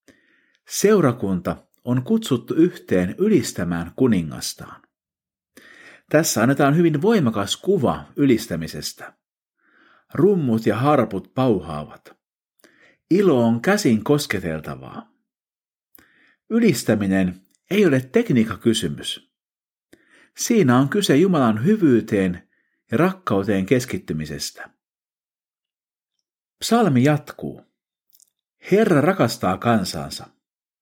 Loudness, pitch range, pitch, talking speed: -20 LUFS, 95-150 Hz, 115 Hz, 70 wpm